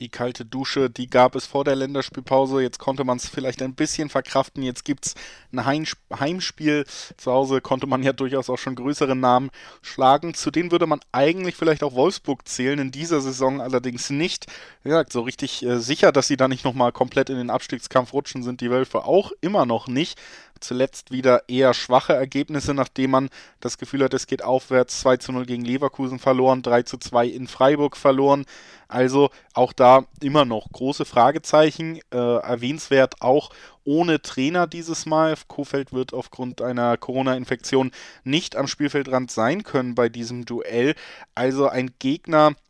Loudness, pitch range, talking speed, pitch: -22 LUFS, 125-140 Hz, 175 wpm, 130 Hz